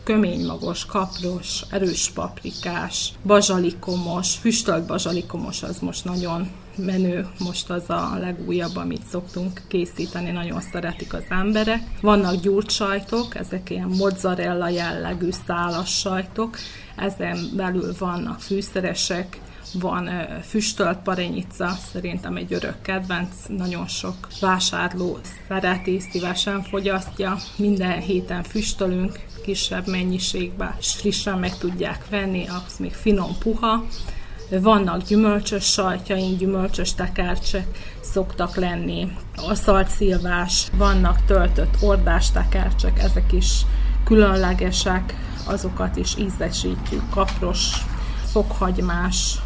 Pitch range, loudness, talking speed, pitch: 175-200 Hz, -23 LUFS, 100 wpm, 185 Hz